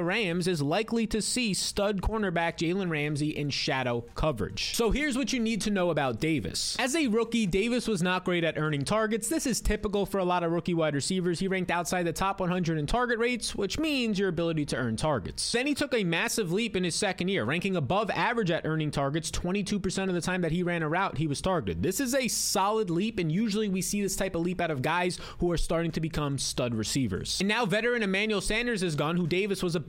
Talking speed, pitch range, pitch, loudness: 240 wpm, 165-215 Hz, 185 Hz, -28 LUFS